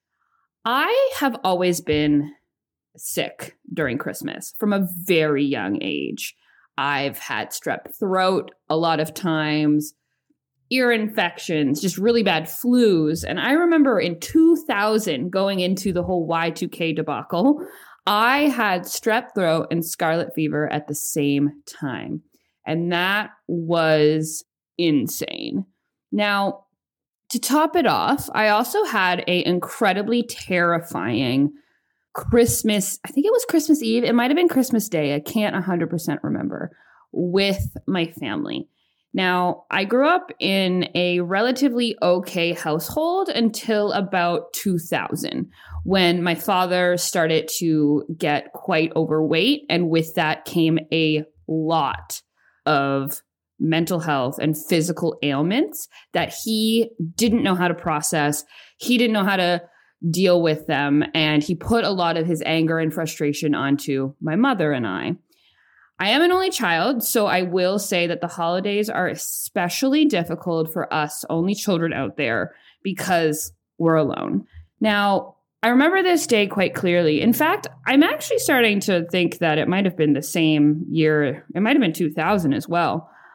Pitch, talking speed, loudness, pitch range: 175 Hz, 145 wpm, -21 LUFS, 160-225 Hz